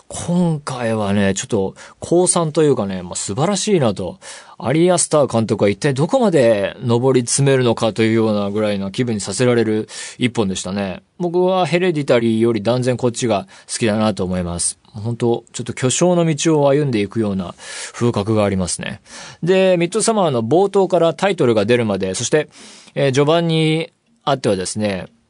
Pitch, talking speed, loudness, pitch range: 120 Hz, 370 characters per minute, -17 LUFS, 105-160 Hz